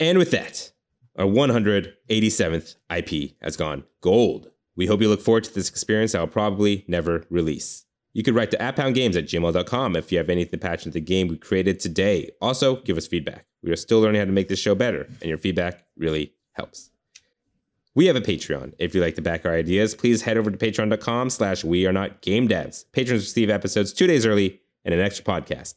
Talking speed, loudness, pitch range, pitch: 210 wpm, -22 LUFS, 85-110 Hz, 95 Hz